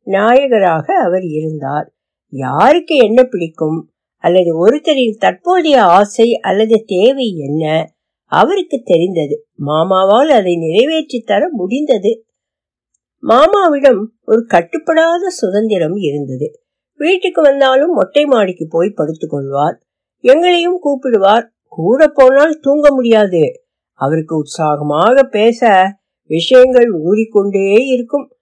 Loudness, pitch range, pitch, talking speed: -12 LUFS, 175-285 Hz, 230 Hz, 85 wpm